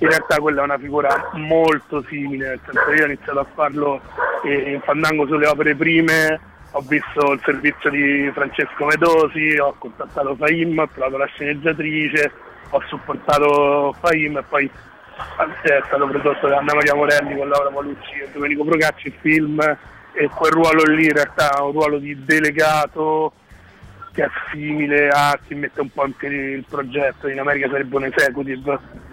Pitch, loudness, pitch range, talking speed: 145 Hz, -18 LUFS, 140-155 Hz, 165 wpm